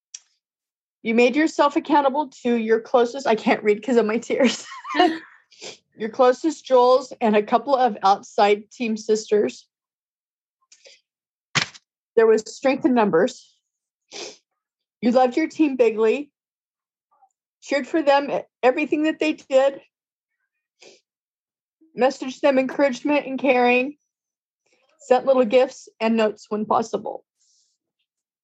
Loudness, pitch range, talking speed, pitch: -20 LUFS, 230-295 Hz, 115 wpm, 260 Hz